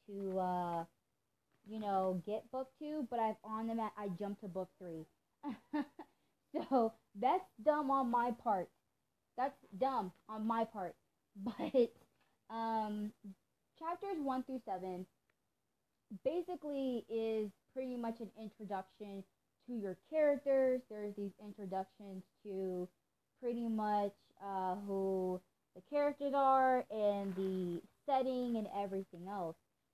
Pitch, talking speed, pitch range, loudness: 215 Hz, 120 wpm, 195-260 Hz, -39 LUFS